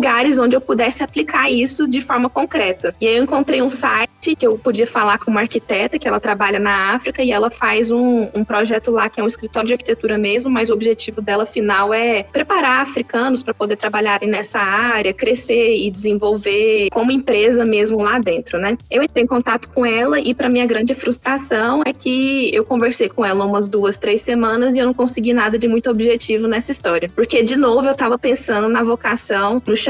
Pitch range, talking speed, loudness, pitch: 215-255 Hz, 205 wpm, -16 LUFS, 235 Hz